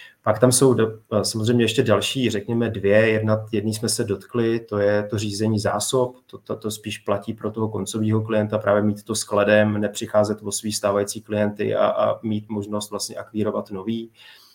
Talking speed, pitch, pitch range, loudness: 180 wpm, 110 Hz, 105-115 Hz, -22 LUFS